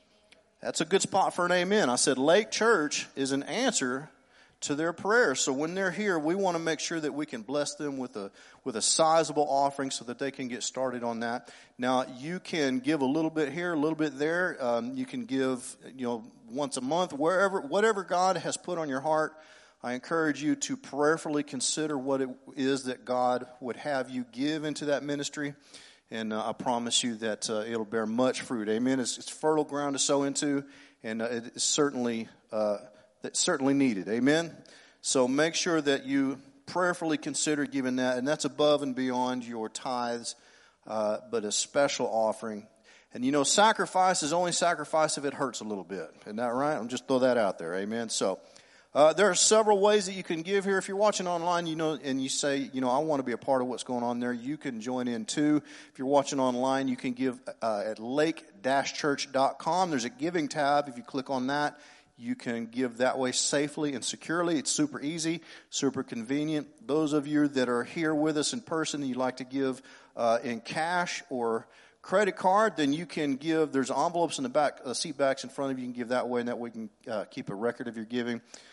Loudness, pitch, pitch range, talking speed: -29 LUFS, 140 Hz, 125-160 Hz, 220 wpm